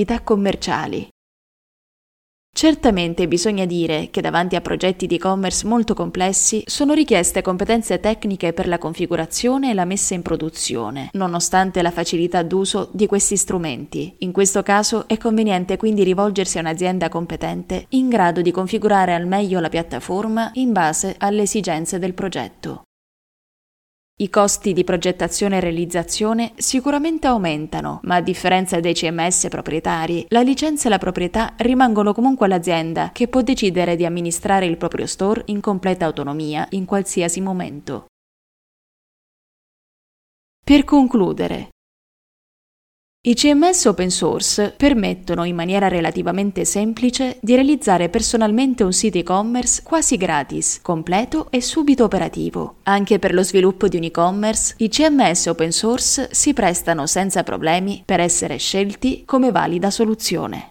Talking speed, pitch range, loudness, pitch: 135 wpm, 175-225 Hz, -18 LUFS, 190 Hz